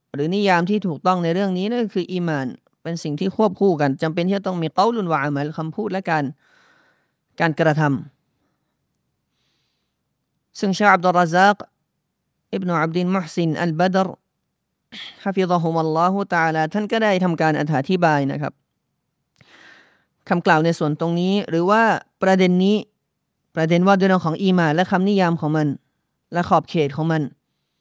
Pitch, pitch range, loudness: 175 Hz, 155-190 Hz, -20 LUFS